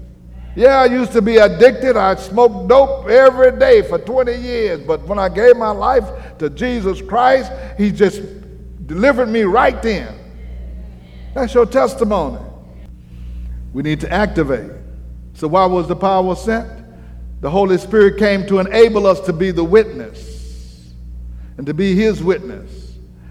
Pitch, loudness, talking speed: 190 Hz, -14 LUFS, 150 wpm